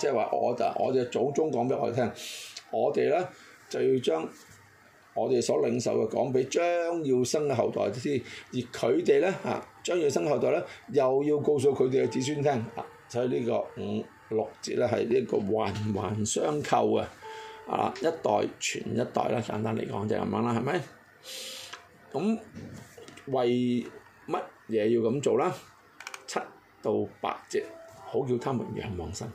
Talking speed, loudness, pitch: 225 characters per minute, -29 LUFS, 145 Hz